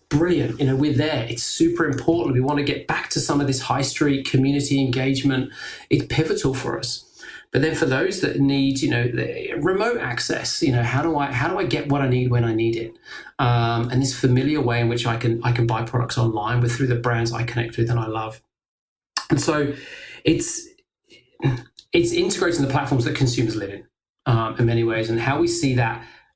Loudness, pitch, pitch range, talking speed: -21 LUFS, 130 Hz, 120-145 Hz, 220 wpm